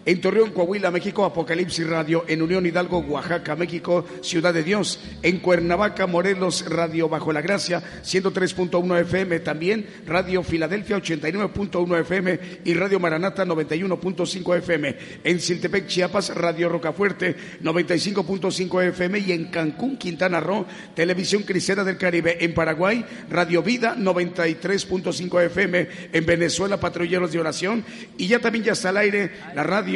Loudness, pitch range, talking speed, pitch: -22 LUFS, 170-195 Hz, 140 wpm, 180 Hz